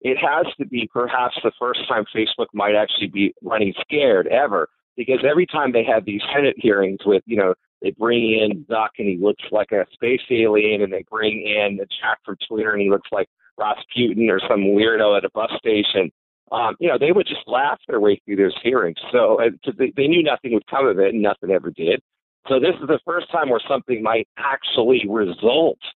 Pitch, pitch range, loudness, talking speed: 110 Hz, 100-130 Hz, -19 LUFS, 215 wpm